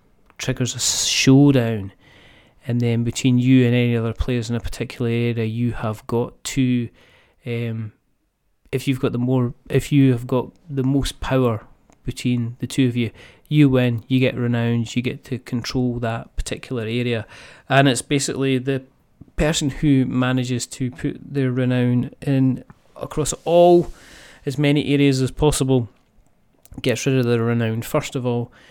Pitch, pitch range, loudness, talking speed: 125 Hz, 120-135 Hz, -20 LUFS, 160 wpm